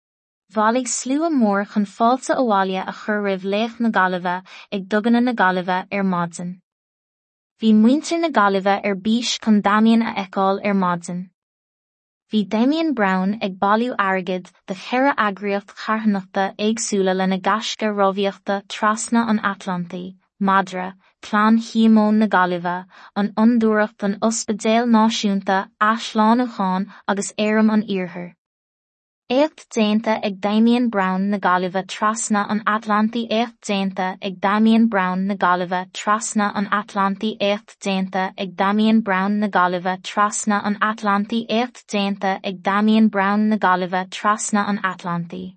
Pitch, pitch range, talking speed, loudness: 205 Hz, 190-220 Hz, 125 wpm, -19 LUFS